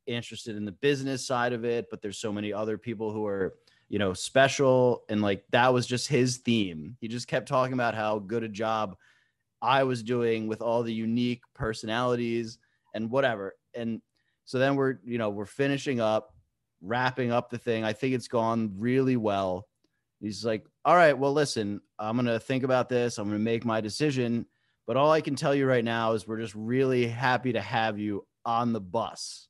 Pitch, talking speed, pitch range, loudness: 115 Hz, 205 wpm, 110-125 Hz, -28 LUFS